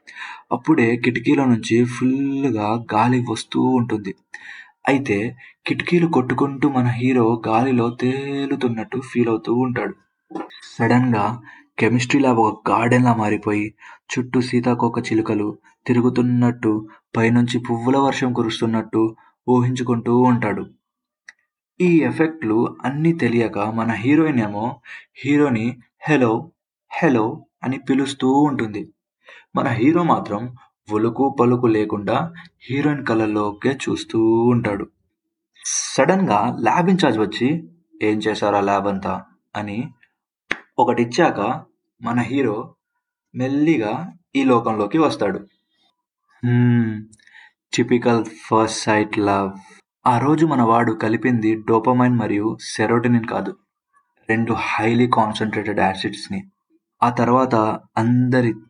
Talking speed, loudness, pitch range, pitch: 100 wpm, -19 LUFS, 110-135 Hz, 120 Hz